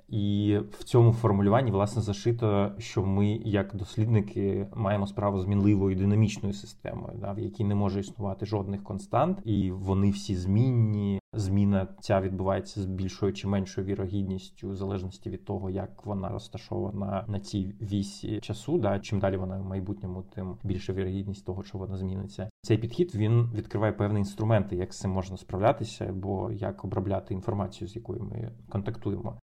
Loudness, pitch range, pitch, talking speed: -29 LUFS, 95-110 Hz, 100 Hz, 160 wpm